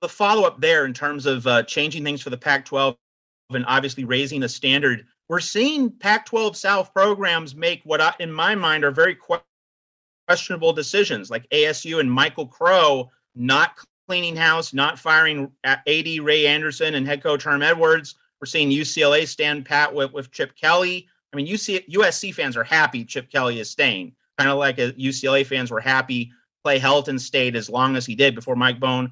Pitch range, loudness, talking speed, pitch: 135-170 Hz, -20 LUFS, 190 wpm, 145 Hz